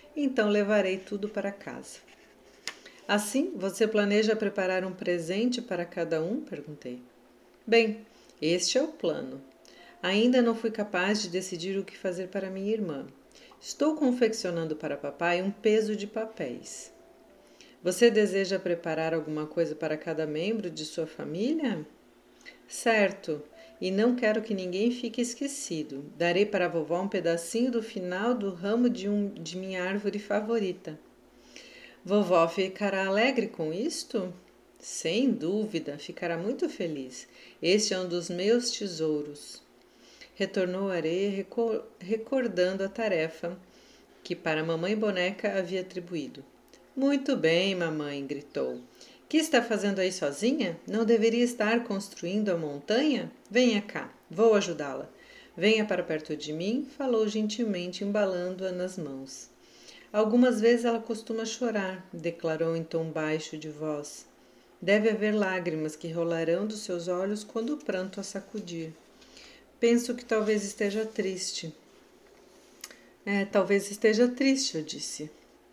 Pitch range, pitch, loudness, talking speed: 170-225 Hz, 195 Hz, -29 LUFS, 130 wpm